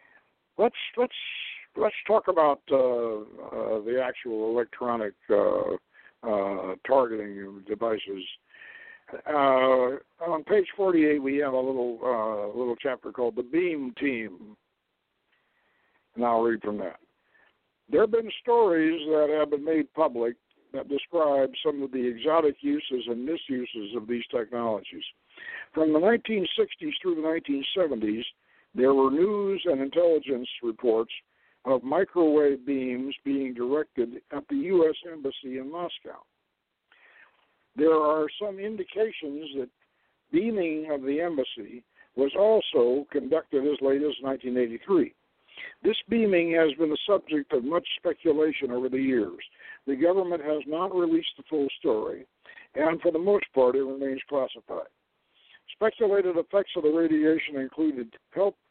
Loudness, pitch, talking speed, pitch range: -27 LUFS, 150 Hz, 130 wpm, 130-185 Hz